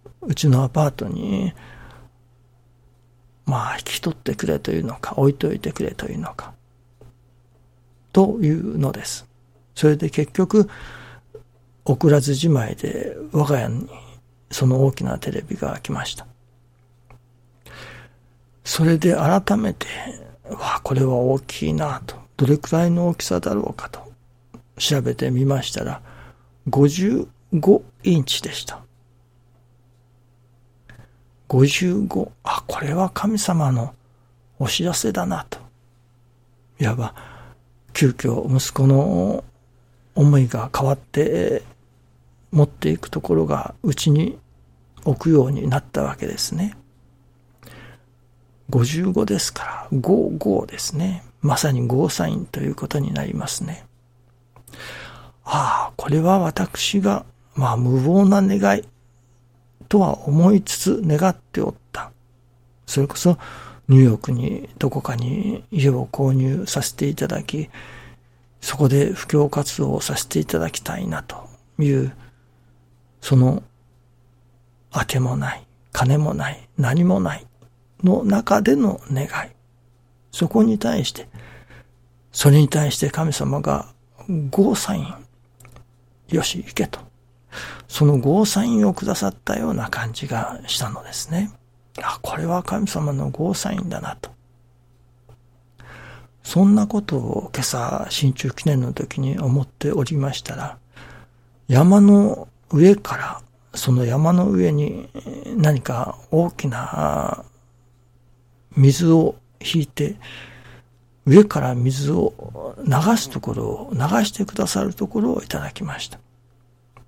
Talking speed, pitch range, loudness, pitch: 215 characters per minute, 120-155 Hz, -20 LUFS, 130 Hz